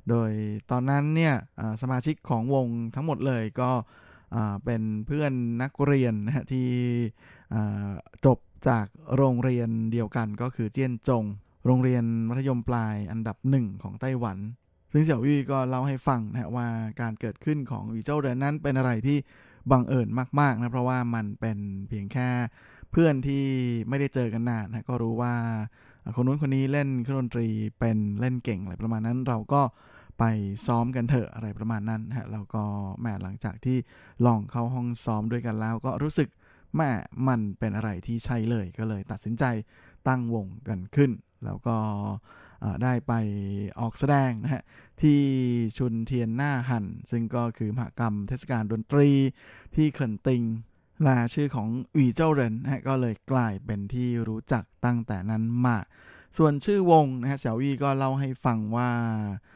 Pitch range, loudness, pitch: 110-130 Hz, -27 LUFS, 120 Hz